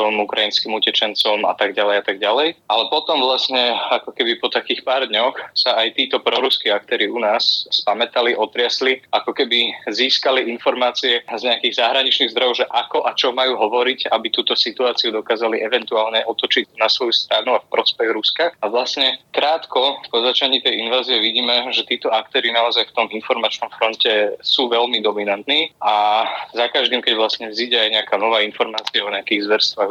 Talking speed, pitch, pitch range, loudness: 170 wpm, 120 Hz, 110-130 Hz, -17 LUFS